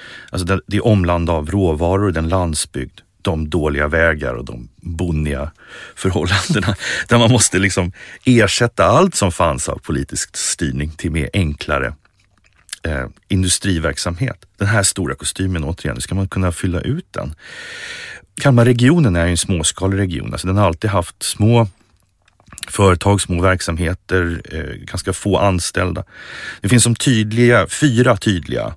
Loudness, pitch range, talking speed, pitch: -17 LUFS, 85-110 Hz, 140 wpm, 95 Hz